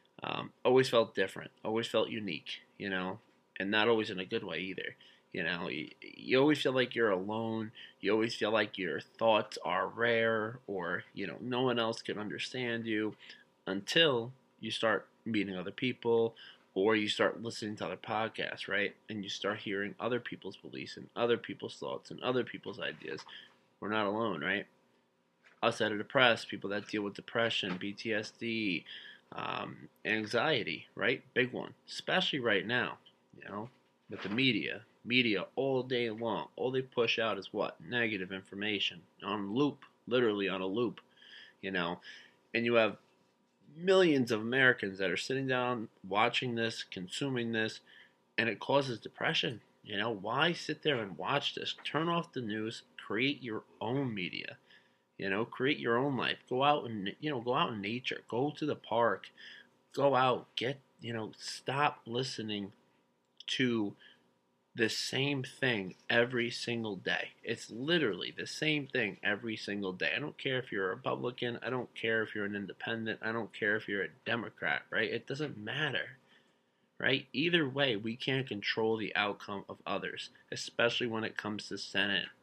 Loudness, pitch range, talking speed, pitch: -34 LUFS, 100-125 Hz, 170 wpm, 115 Hz